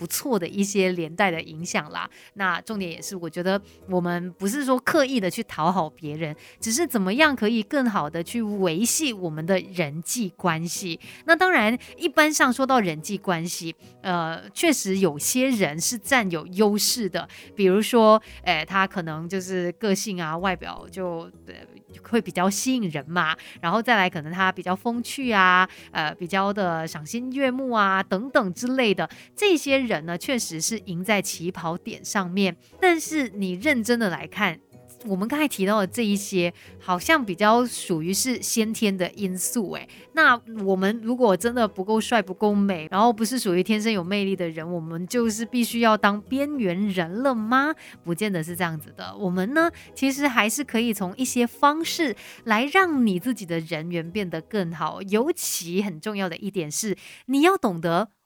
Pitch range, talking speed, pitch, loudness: 175-235 Hz, 265 characters per minute, 200 Hz, -23 LUFS